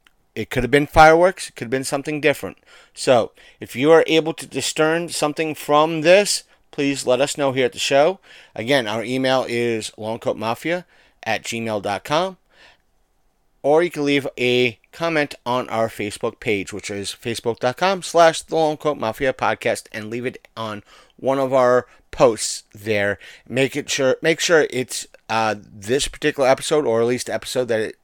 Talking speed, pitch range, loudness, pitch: 170 wpm, 110-155 Hz, -20 LUFS, 130 Hz